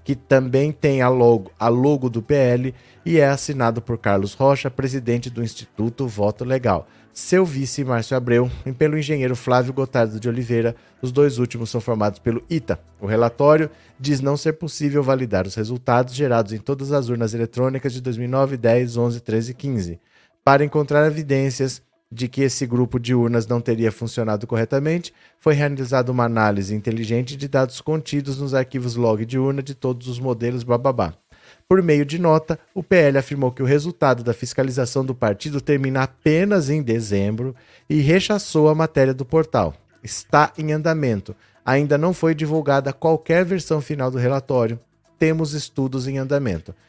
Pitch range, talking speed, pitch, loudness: 120-145 Hz, 170 wpm, 130 Hz, -20 LUFS